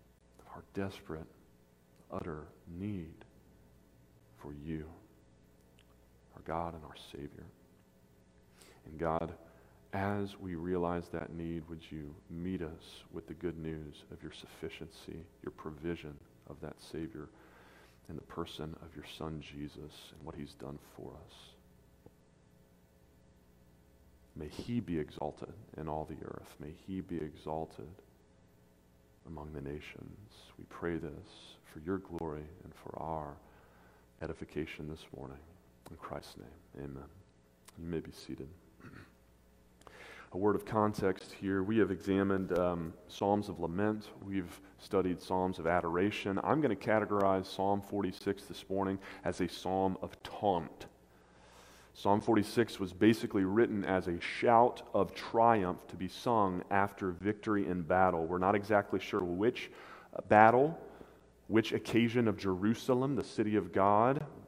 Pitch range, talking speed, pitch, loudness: 70-95 Hz, 135 wpm, 85 Hz, -35 LUFS